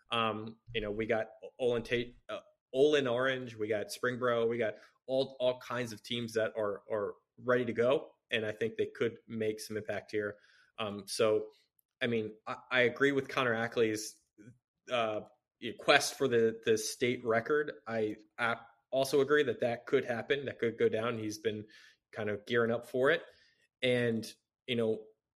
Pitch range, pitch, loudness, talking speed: 110-125 Hz, 115 Hz, -33 LUFS, 180 wpm